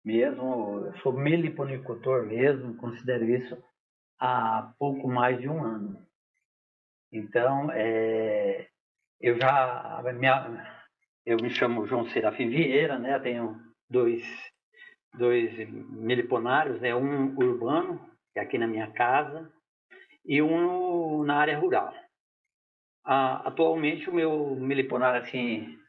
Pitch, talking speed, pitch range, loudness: 130 Hz, 120 wpm, 120-160 Hz, -27 LUFS